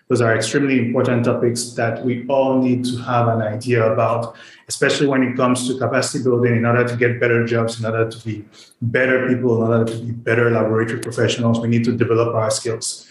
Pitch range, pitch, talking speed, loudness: 115-125 Hz, 120 Hz, 210 wpm, -18 LUFS